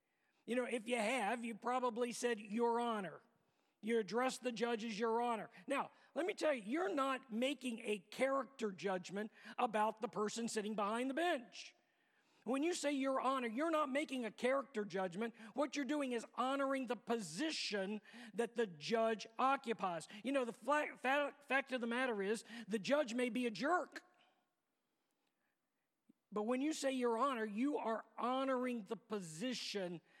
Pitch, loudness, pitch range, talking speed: 245 Hz, -40 LUFS, 225-275 Hz, 165 wpm